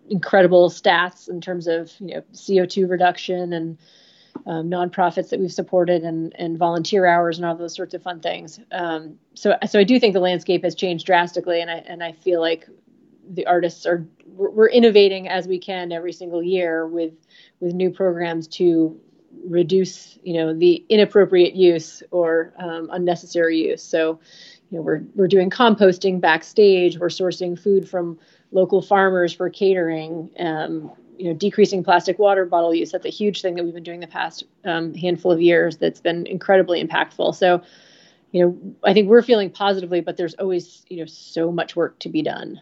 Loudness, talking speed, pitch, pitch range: -19 LUFS, 180 wpm, 175 Hz, 170-190 Hz